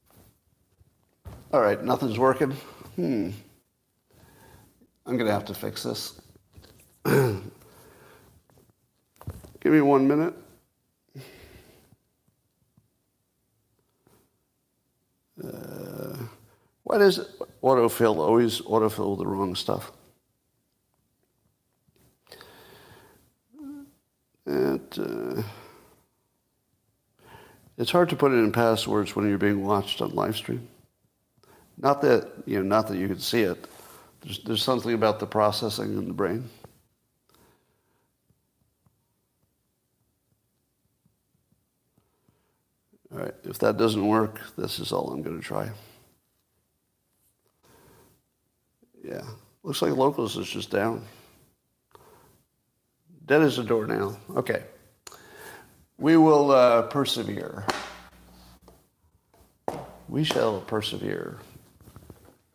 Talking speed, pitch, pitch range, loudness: 90 wpm, 115 Hz, 105-135 Hz, -25 LUFS